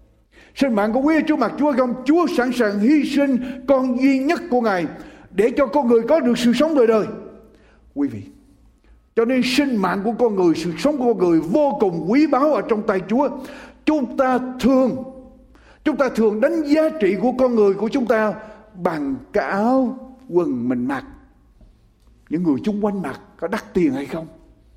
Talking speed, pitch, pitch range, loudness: 200 wpm, 255 Hz, 215-280 Hz, -19 LUFS